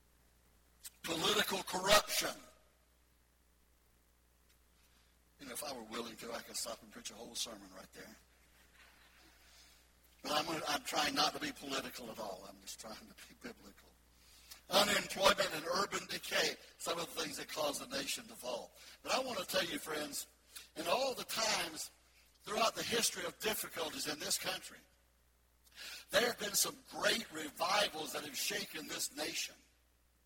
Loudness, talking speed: -37 LUFS, 155 wpm